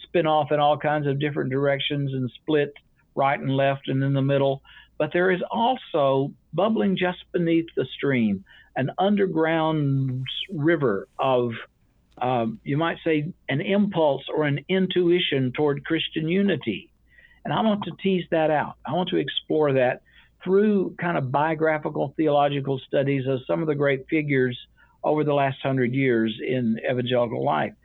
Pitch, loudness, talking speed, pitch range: 145 Hz, -24 LUFS, 160 wpm, 135-170 Hz